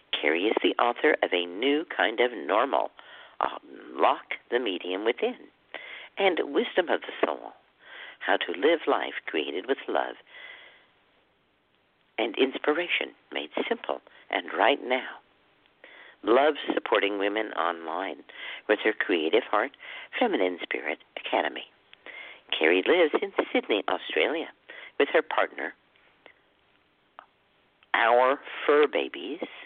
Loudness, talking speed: -27 LUFS, 115 wpm